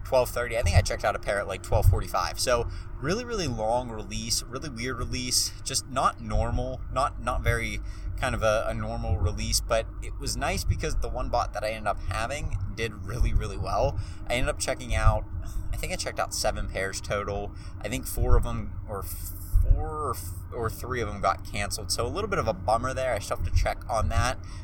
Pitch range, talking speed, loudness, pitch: 95-115 Hz, 220 wpm, -29 LUFS, 100 Hz